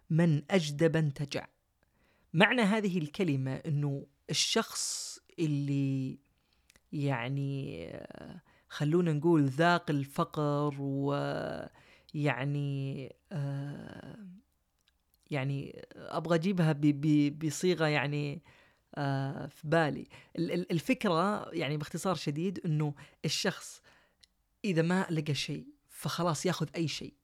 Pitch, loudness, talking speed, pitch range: 150 Hz, -32 LUFS, 90 wpm, 140-170 Hz